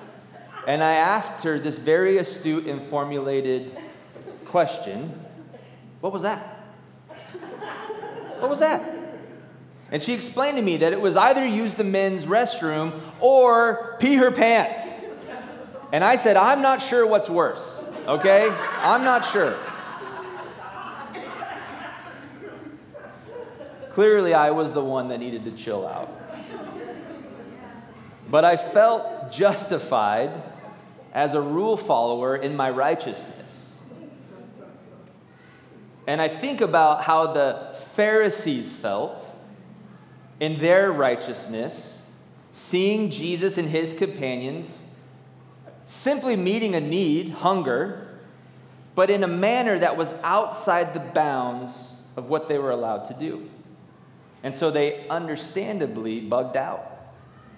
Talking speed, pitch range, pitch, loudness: 115 wpm, 150-220 Hz, 180 Hz, -22 LUFS